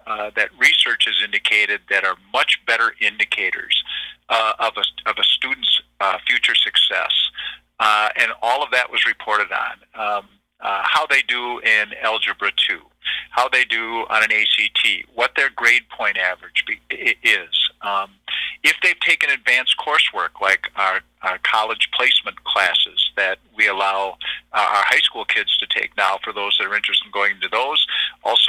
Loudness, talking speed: -17 LUFS, 170 wpm